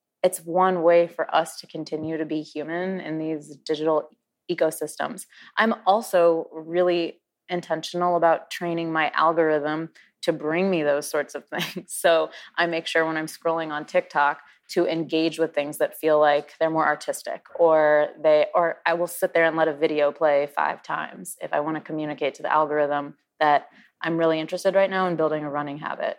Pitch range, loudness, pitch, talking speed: 150-170 Hz, -24 LUFS, 160 Hz, 185 wpm